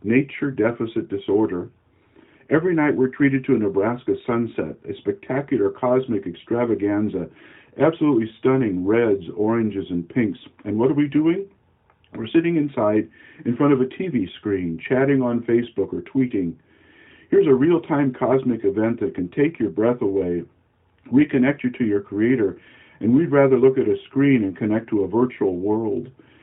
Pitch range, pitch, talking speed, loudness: 105-135 Hz, 120 Hz, 160 wpm, -21 LUFS